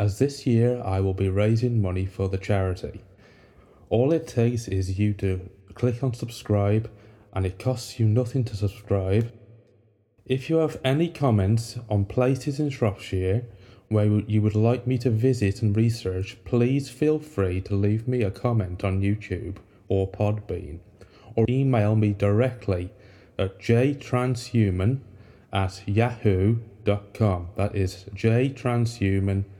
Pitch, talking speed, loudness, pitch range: 105 Hz, 140 wpm, -25 LUFS, 100-120 Hz